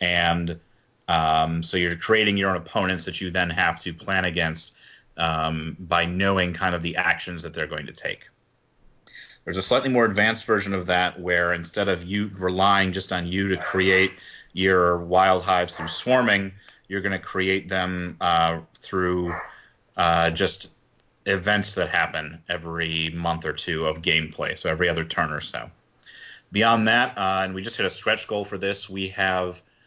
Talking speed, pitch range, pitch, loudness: 175 wpm, 85-95 Hz, 95 Hz, -23 LUFS